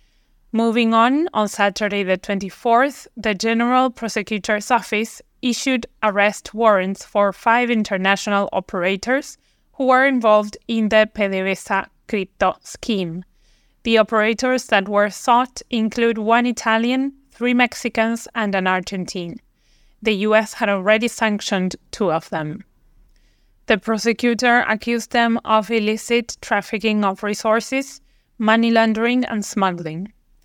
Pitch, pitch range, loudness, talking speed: 220 Hz, 205-235 Hz, -19 LUFS, 115 wpm